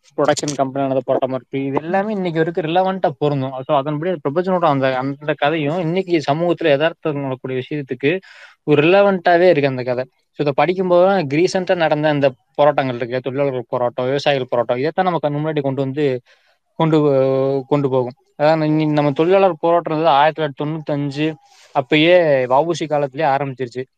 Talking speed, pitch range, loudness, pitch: 150 wpm, 135-170 Hz, -17 LUFS, 150 Hz